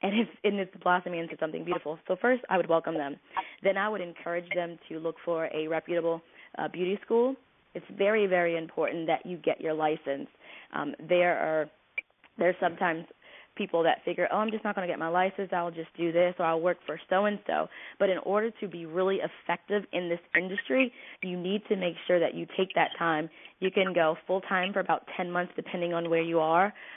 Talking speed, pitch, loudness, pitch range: 215 wpm, 175 Hz, -30 LUFS, 165-195 Hz